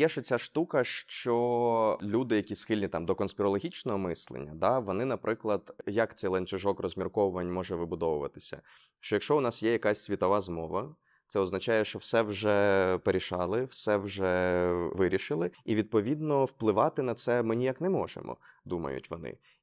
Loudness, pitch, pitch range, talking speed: -30 LUFS, 105 Hz, 95-120 Hz, 150 wpm